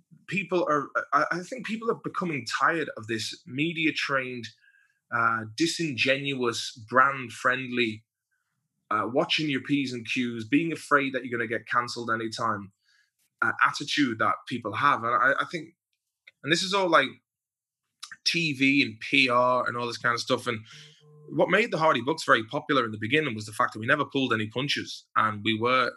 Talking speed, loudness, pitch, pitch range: 180 wpm, -26 LUFS, 130 Hz, 120-155 Hz